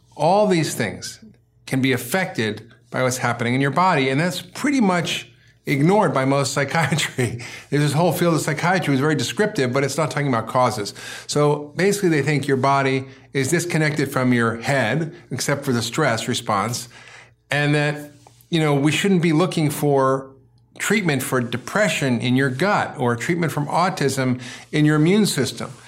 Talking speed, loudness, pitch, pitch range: 170 wpm, -20 LUFS, 140 Hz, 125-160 Hz